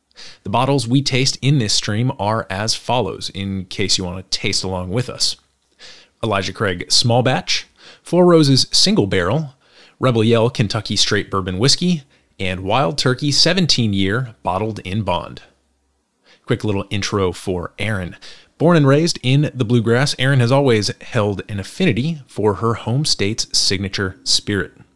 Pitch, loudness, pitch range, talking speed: 115 Hz, -17 LUFS, 95-135 Hz, 155 wpm